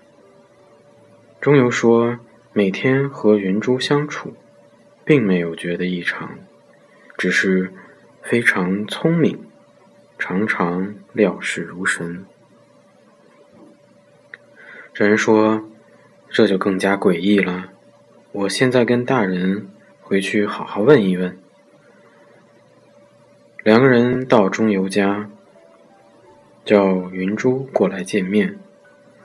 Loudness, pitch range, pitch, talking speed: -18 LUFS, 95-120 Hz, 105 Hz, 135 characters per minute